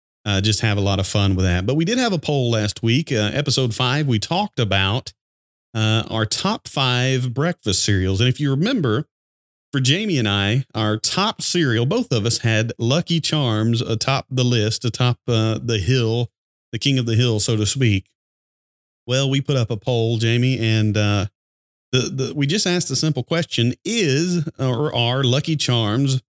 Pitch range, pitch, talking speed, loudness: 110-135 Hz, 120 Hz, 190 wpm, -19 LUFS